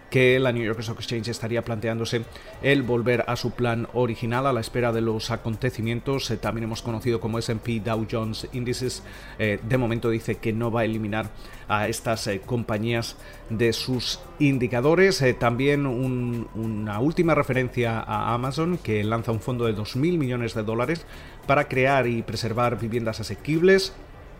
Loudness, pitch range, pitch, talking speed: -25 LUFS, 115-125 Hz, 115 Hz, 155 wpm